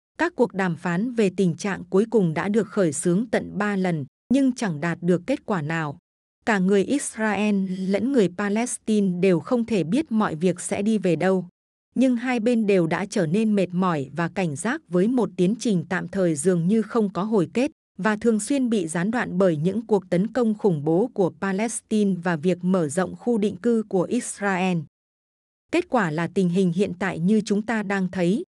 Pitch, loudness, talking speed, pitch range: 200 Hz, -23 LUFS, 210 wpm, 180-225 Hz